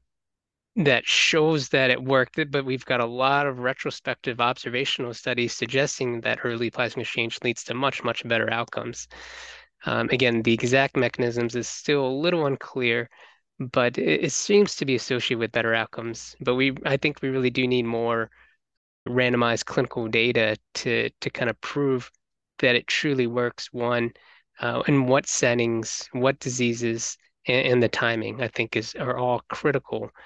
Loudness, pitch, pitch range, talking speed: -24 LUFS, 125 Hz, 120-135 Hz, 165 wpm